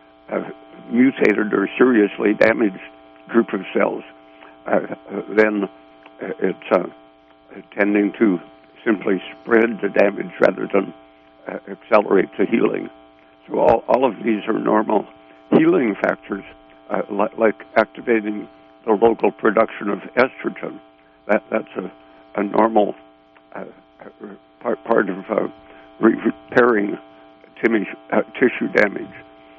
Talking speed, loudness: 115 wpm, -19 LUFS